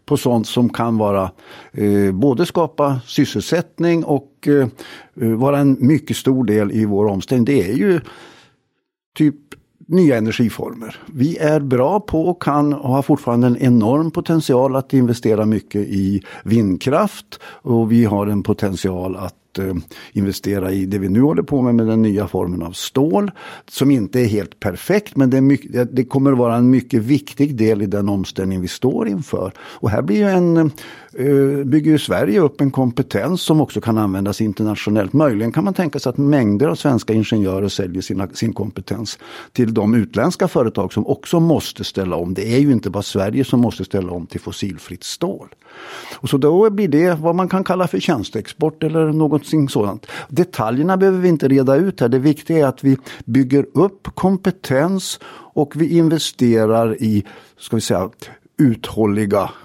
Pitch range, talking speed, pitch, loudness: 105-150 Hz, 175 wpm, 125 Hz, -17 LUFS